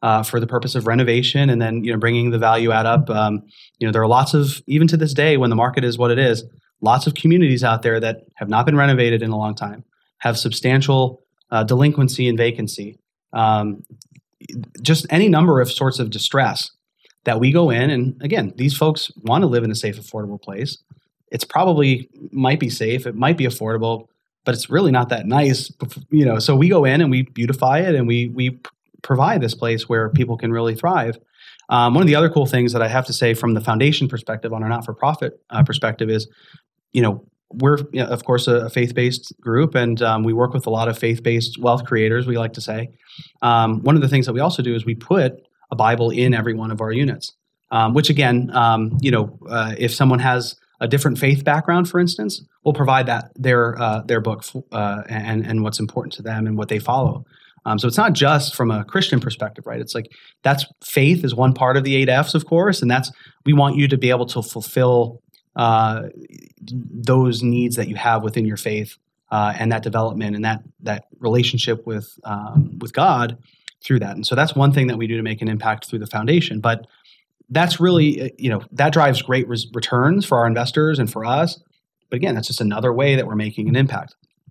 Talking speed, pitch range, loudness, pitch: 225 wpm, 115-140 Hz, -18 LUFS, 120 Hz